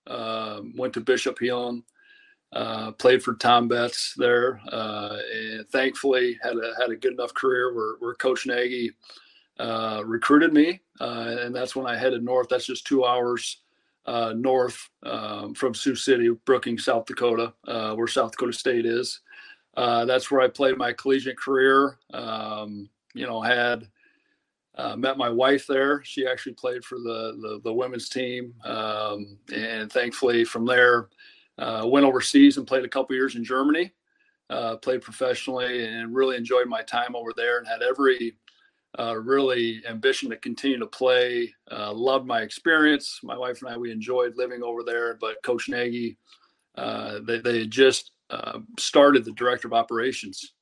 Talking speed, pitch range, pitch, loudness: 165 wpm, 115-135 Hz, 125 Hz, -24 LUFS